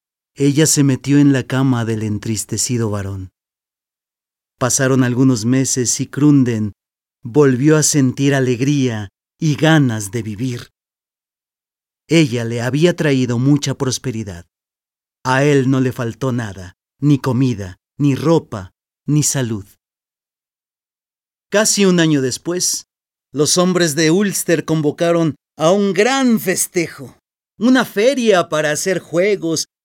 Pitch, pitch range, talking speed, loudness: 135 Hz, 120-160 Hz, 115 wpm, -16 LUFS